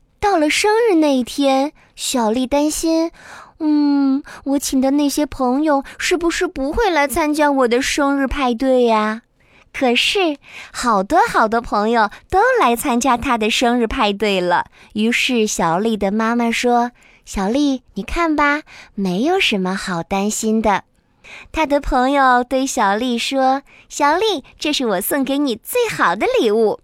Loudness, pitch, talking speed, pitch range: -17 LUFS, 270 Hz, 215 characters per minute, 230-300 Hz